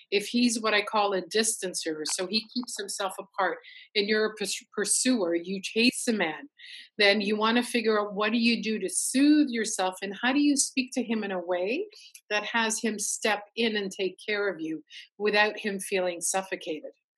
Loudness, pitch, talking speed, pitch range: -27 LUFS, 210 Hz, 200 wpm, 195-235 Hz